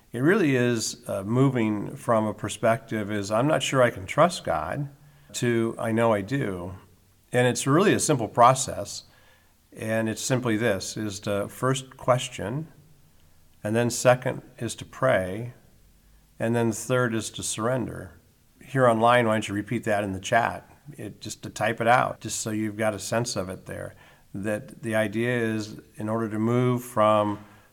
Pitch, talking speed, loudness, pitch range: 115 Hz, 175 wpm, -25 LUFS, 105-125 Hz